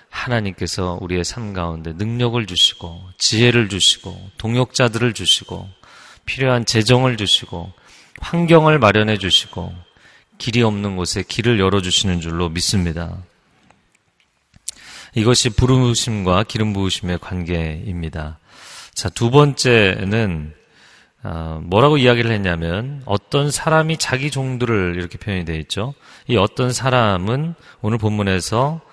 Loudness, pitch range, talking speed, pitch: -17 LUFS, 90-125 Hz, 275 characters per minute, 105 Hz